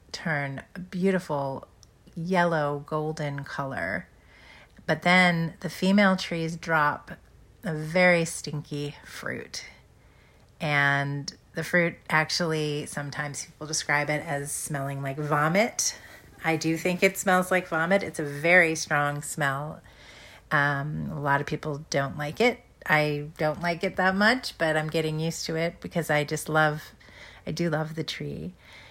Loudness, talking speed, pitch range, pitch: -26 LUFS, 145 wpm, 145-170 Hz, 155 Hz